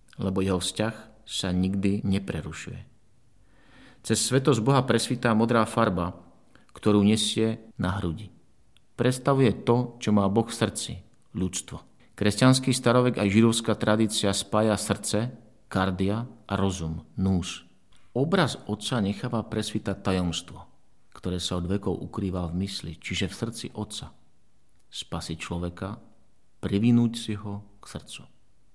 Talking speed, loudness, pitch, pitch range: 125 wpm, -26 LUFS, 105 Hz, 95-115 Hz